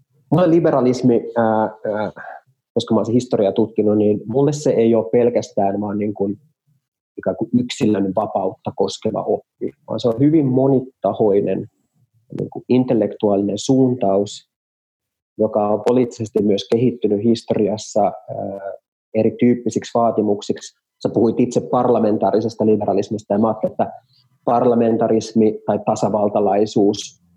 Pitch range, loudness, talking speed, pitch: 105-125 Hz, -18 LUFS, 120 wpm, 115 Hz